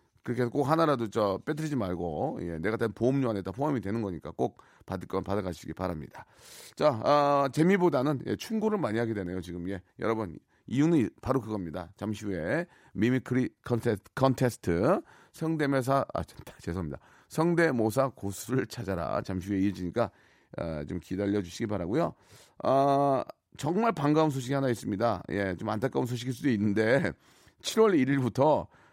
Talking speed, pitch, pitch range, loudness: 355 characters per minute, 115 Hz, 95-135 Hz, -29 LUFS